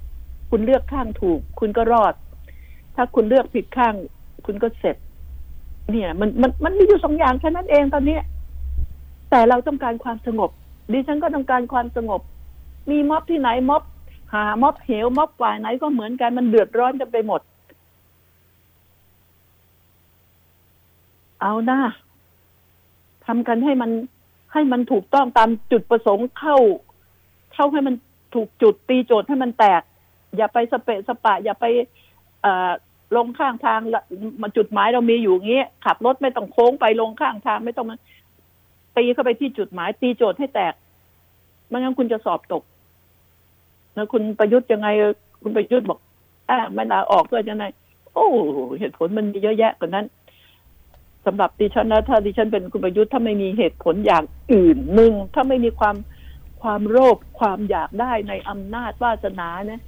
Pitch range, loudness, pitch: 165-250 Hz, -19 LUFS, 225 Hz